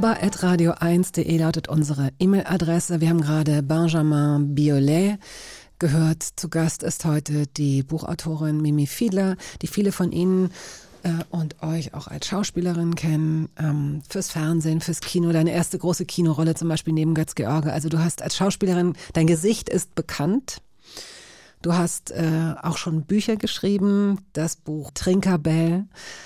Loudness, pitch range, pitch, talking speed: -23 LUFS, 155-180 Hz, 165 Hz, 135 wpm